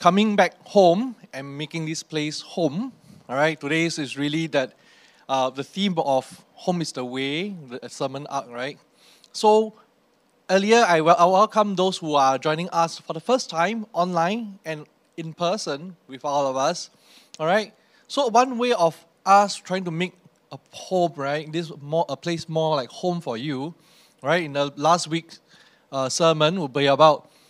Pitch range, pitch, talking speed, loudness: 145-185 Hz, 165 Hz, 175 wpm, -23 LUFS